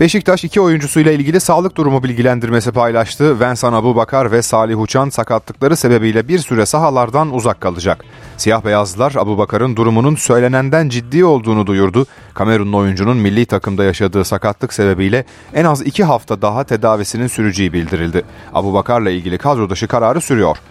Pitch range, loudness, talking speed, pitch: 105-135 Hz, -14 LUFS, 140 wpm, 120 Hz